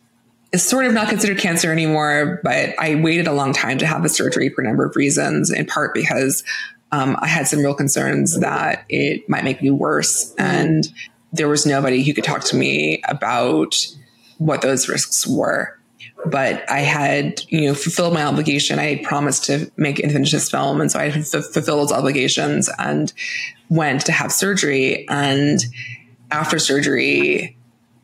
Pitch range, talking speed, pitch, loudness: 135-170 Hz, 180 wpm, 150 Hz, -18 LUFS